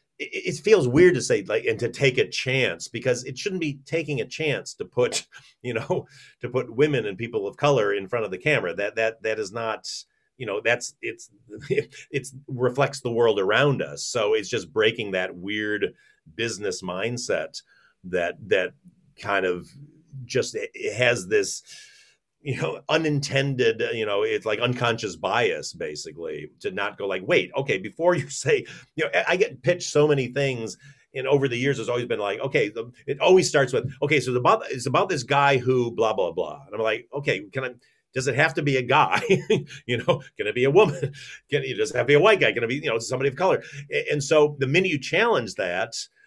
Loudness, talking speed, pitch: -24 LUFS, 210 wpm, 155 Hz